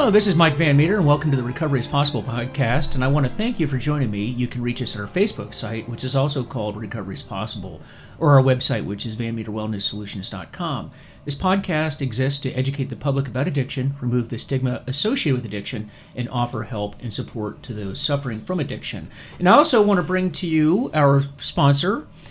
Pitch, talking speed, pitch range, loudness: 130 Hz, 210 wpm, 115-150 Hz, -21 LUFS